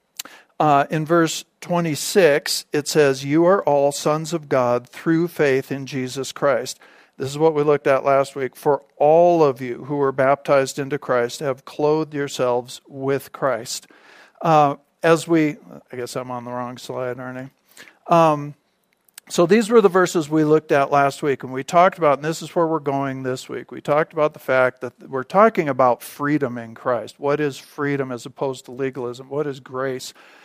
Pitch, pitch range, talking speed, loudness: 140 Hz, 130-155 Hz, 195 wpm, -20 LUFS